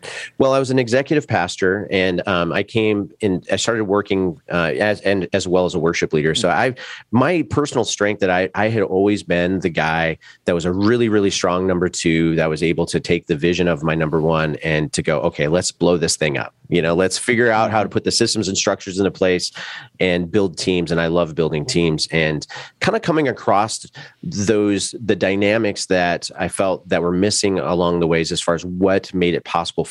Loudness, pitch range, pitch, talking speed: -18 LUFS, 85-105 Hz, 95 Hz, 225 wpm